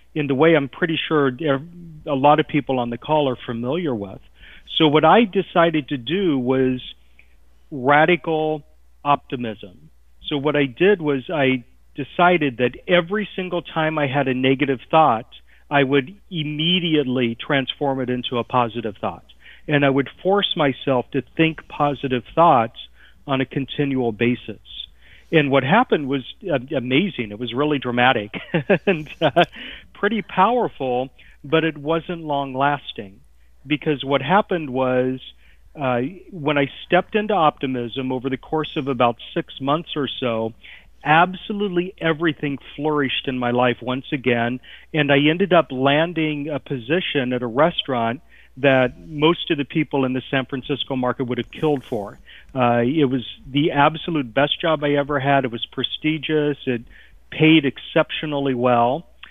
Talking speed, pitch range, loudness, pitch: 150 wpm, 125-155 Hz, -20 LUFS, 140 Hz